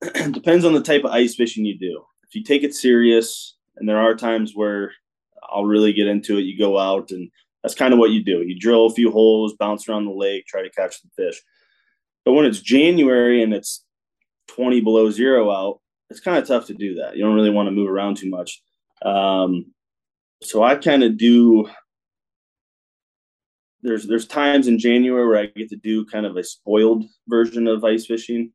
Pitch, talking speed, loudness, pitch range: 110 Hz, 210 wpm, -18 LUFS, 105-120 Hz